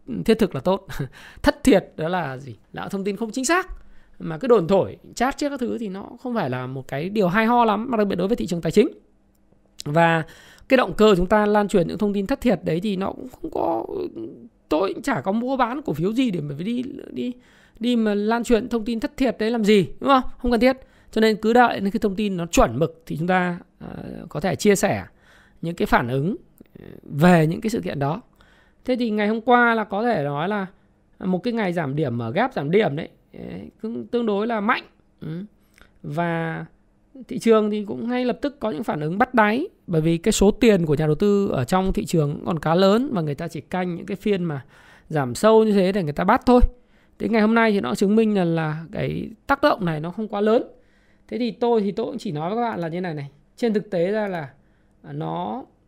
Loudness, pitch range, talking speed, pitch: -22 LUFS, 170-235 Hz, 245 wpm, 210 Hz